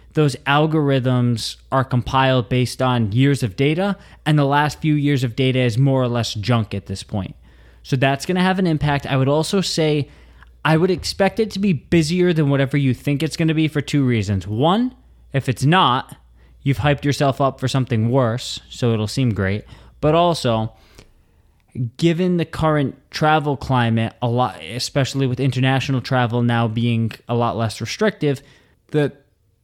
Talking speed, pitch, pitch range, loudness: 180 wpm, 130 Hz, 115-150 Hz, -19 LUFS